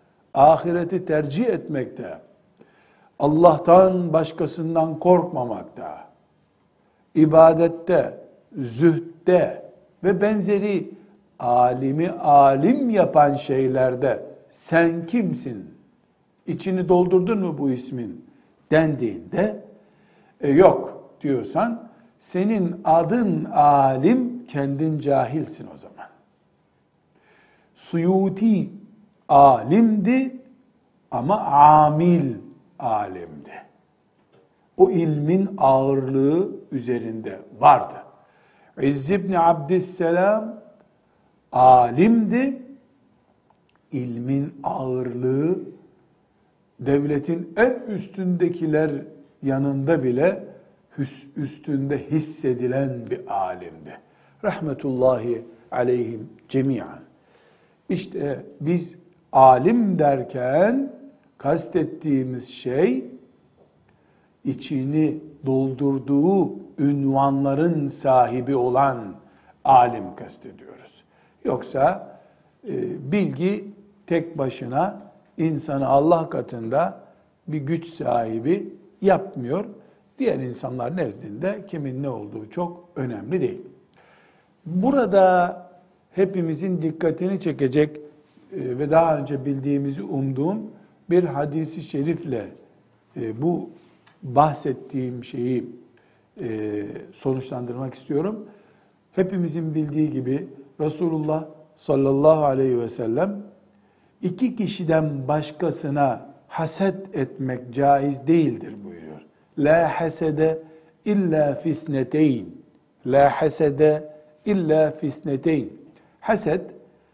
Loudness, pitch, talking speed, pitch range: -21 LUFS, 155 Hz, 70 wpm, 140-185 Hz